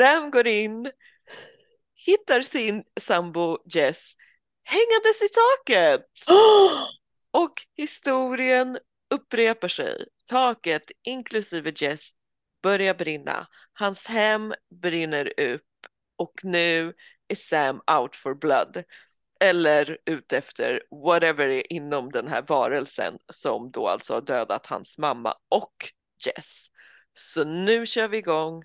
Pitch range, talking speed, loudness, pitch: 170-260 Hz, 115 wpm, -23 LUFS, 215 Hz